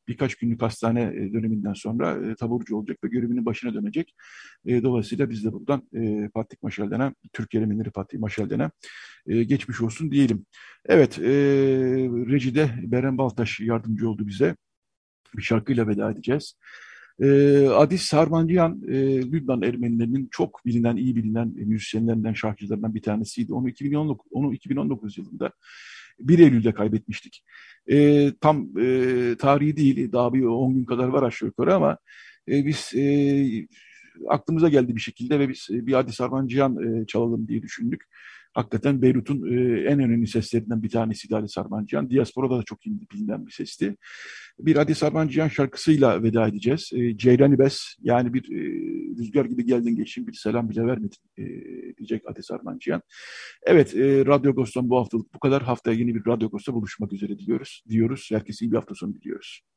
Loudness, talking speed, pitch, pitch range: -23 LUFS, 150 wpm, 125 Hz, 115-140 Hz